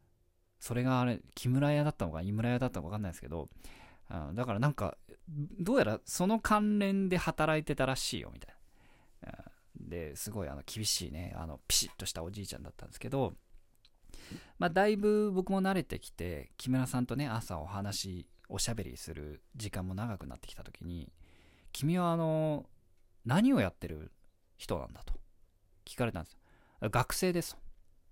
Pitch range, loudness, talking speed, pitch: 90-135 Hz, -34 LUFS, 345 characters per minute, 100 Hz